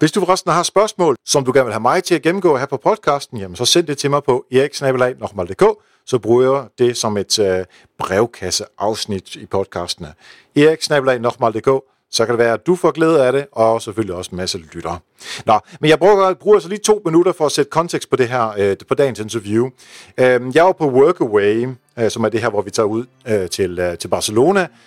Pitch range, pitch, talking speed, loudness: 110-160 Hz, 130 Hz, 220 wpm, -16 LUFS